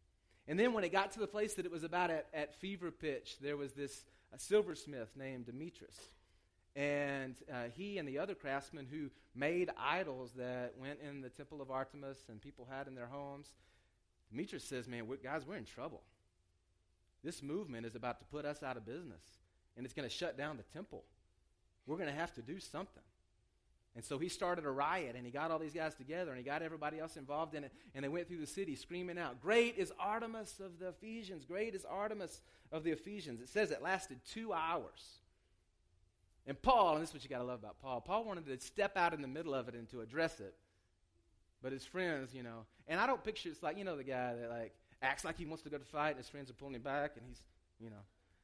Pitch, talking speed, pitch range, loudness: 140 Hz, 235 wpm, 120-170 Hz, -42 LUFS